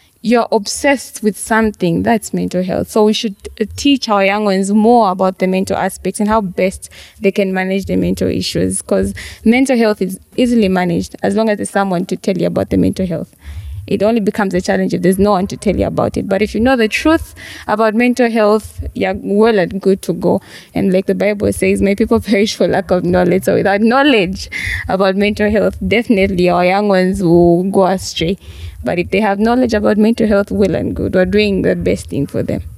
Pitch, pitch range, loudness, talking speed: 200 Hz, 185-220 Hz, -14 LUFS, 220 wpm